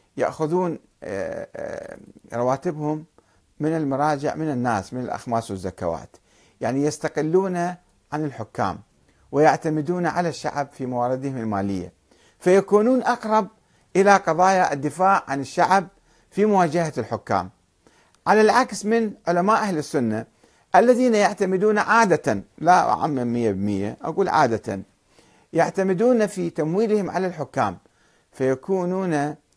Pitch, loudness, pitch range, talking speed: 155 Hz, -22 LUFS, 120-190 Hz, 100 wpm